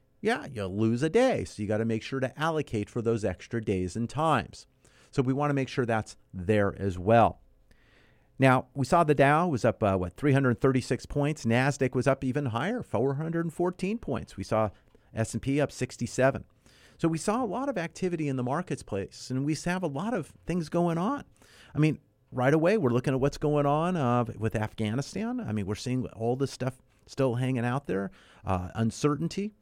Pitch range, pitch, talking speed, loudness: 110-150 Hz, 130 Hz, 195 wpm, -28 LUFS